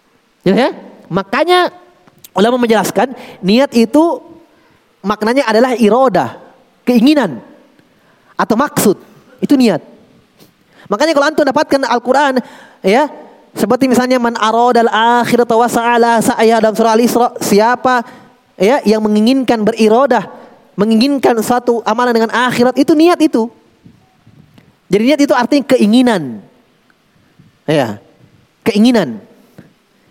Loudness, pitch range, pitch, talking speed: -12 LUFS, 220-260 Hz, 240 Hz, 100 wpm